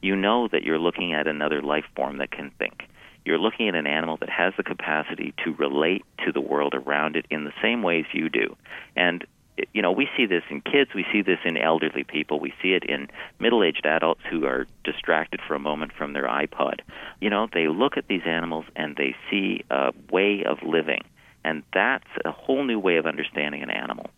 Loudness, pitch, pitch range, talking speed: -25 LUFS, 80 Hz, 75-90 Hz, 220 wpm